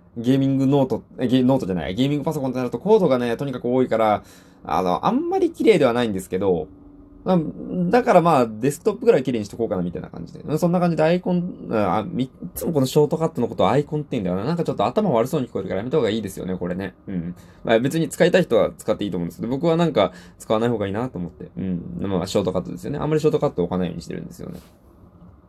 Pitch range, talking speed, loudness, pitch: 95-150 Hz, 570 characters per minute, -21 LUFS, 125 Hz